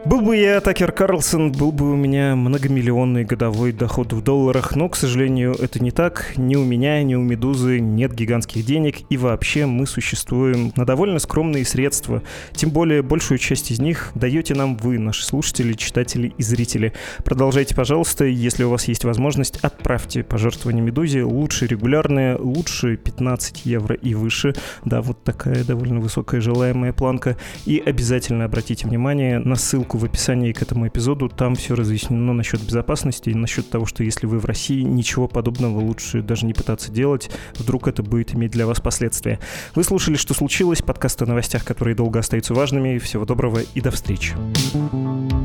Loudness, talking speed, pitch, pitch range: -20 LUFS, 170 wpm, 125 Hz, 115-140 Hz